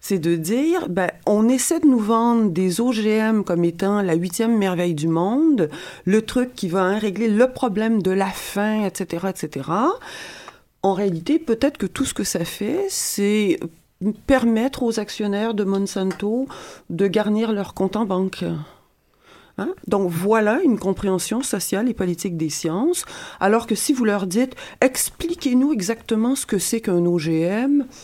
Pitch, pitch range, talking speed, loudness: 210 Hz, 190-250 Hz, 160 wpm, -21 LUFS